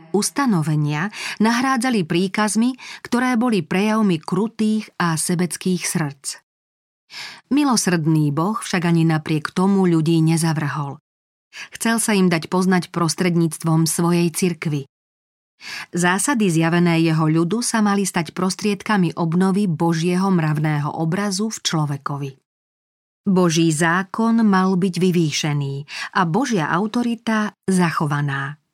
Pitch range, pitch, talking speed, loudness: 160-205 Hz, 175 Hz, 100 wpm, -19 LUFS